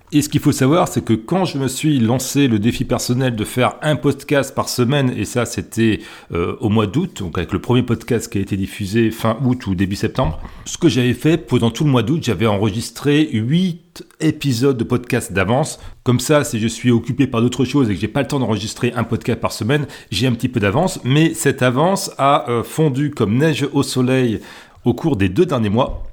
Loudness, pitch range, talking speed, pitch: -18 LUFS, 110-140 Hz, 225 wpm, 125 Hz